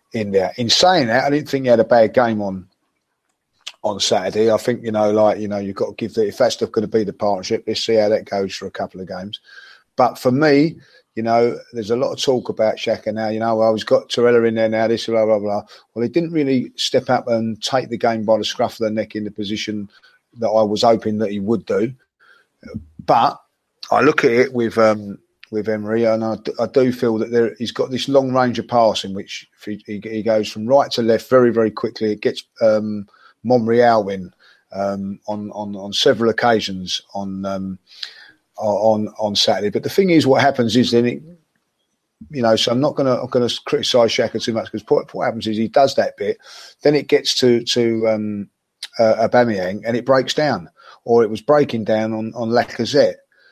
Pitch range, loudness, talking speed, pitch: 105-120 Hz, -18 LUFS, 230 wpm, 110 Hz